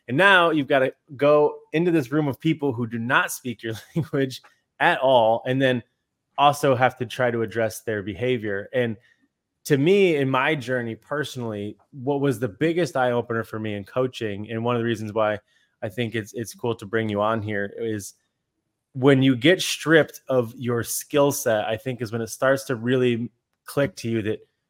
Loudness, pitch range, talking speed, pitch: -23 LUFS, 115-140 Hz, 200 wpm, 125 Hz